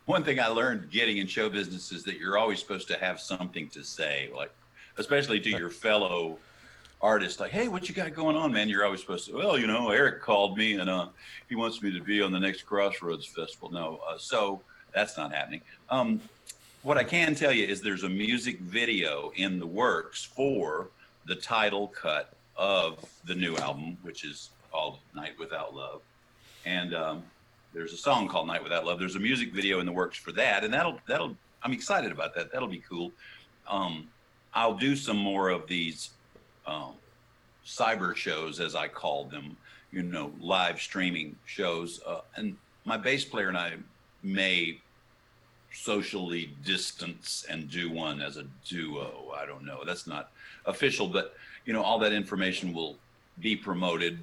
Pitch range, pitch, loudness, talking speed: 90-115 Hz, 100 Hz, -30 LUFS, 185 wpm